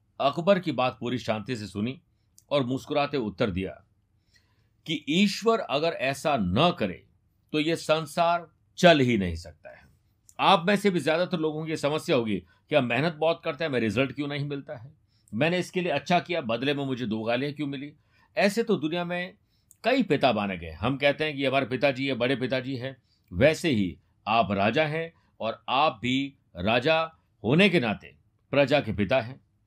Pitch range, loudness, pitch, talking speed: 110-160 Hz, -26 LUFS, 135 Hz, 185 wpm